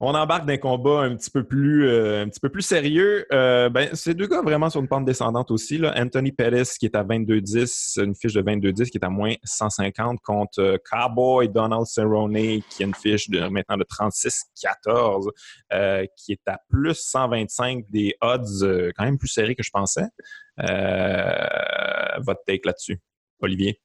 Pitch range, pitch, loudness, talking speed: 105-140 Hz, 120 Hz, -22 LUFS, 185 wpm